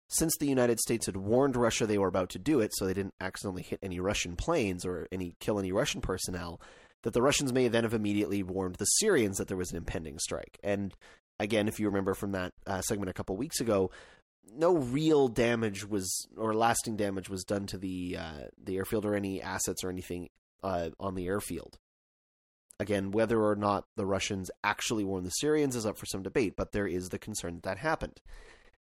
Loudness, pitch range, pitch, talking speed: -31 LUFS, 95-110 Hz, 100 Hz, 210 wpm